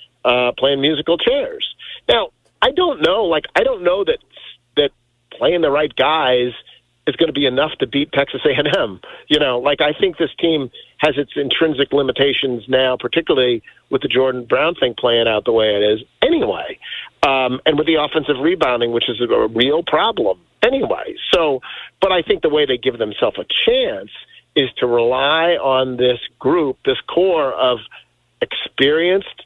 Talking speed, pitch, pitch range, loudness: 175 wpm, 145 Hz, 125-185 Hz, -17 LUFS